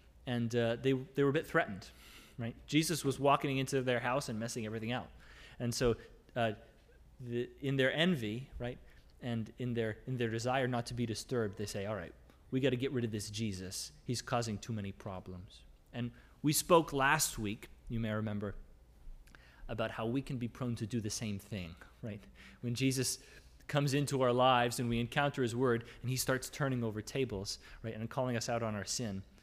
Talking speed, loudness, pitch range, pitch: 200 wpm, -36 LUFS, 105-130 Hz, 120 Hz